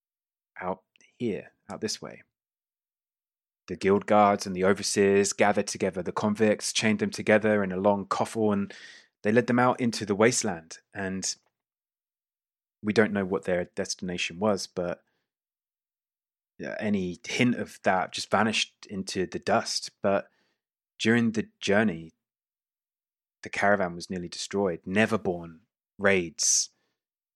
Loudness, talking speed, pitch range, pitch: -27 LUFS, 130 wpm, 95-110 Hz, 100 Hz